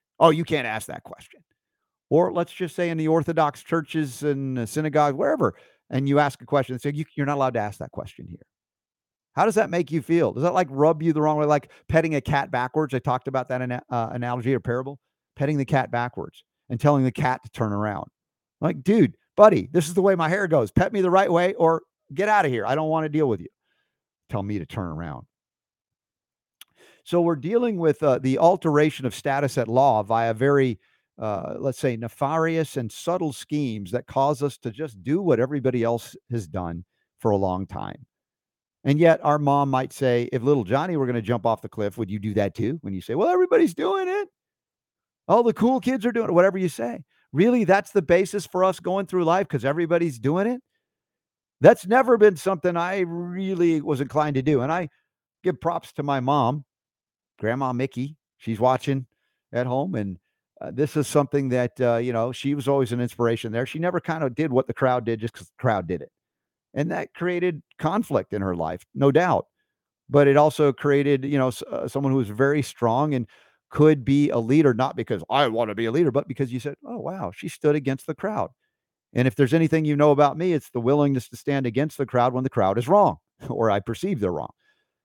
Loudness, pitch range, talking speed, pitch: -23 LUFS, 125-165 Hz, 225 wpm, 140 Hz